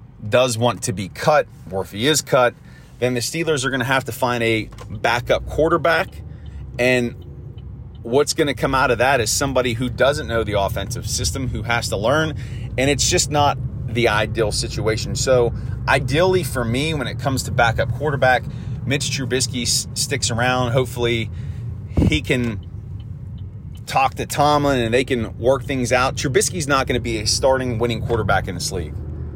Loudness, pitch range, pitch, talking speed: -19 LUFS, 110-130 Hz, 120 Hz, 175 wpm